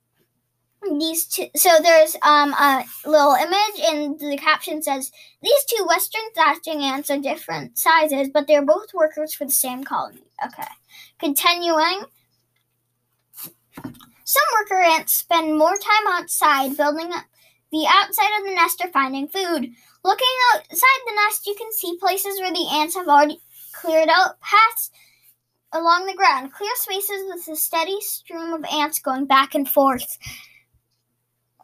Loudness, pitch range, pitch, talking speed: -19 LUFS, 290-380 Hz, 320 Hz, 150 wpm